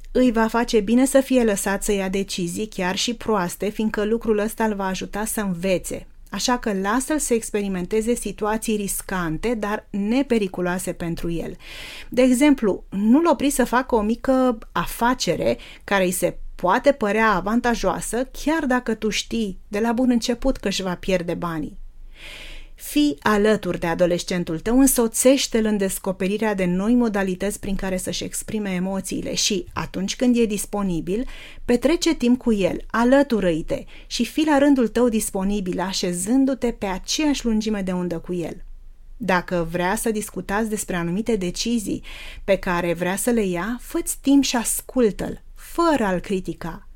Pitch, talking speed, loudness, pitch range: 215 Hz, 155 wpm, -22 LUFS, 185-240 Hz